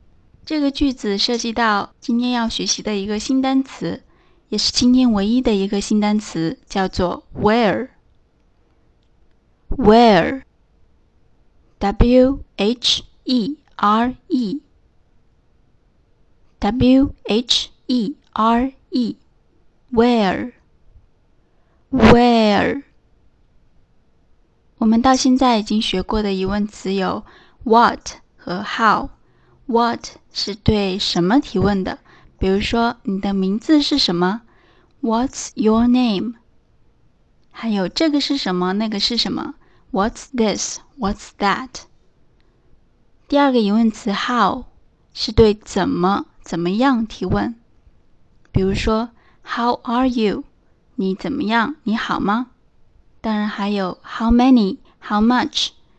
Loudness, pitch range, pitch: -18 LUFS, 205-255 Hz, 230 Hz